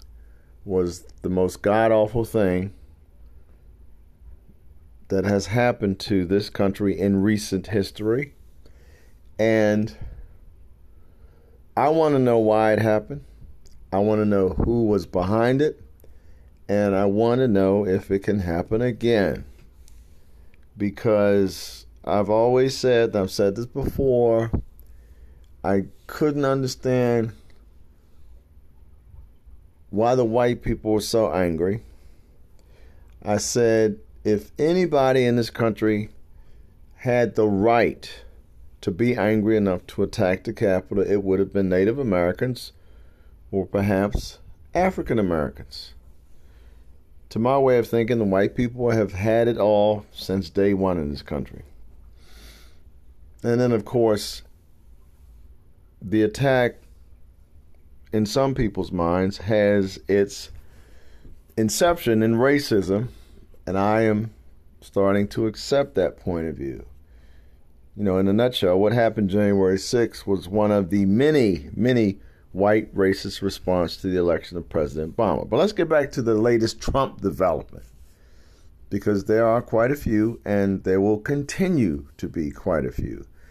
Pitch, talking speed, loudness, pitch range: 95 Hz, 130 wpm, -22 LUFS, 80-110 Hz